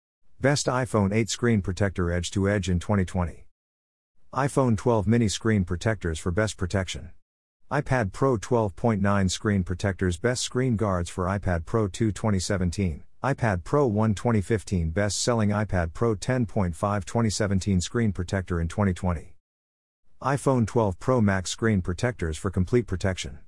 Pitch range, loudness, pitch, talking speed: 90-115 Hz, -26 LUFS, 100 Hz, 140 wpm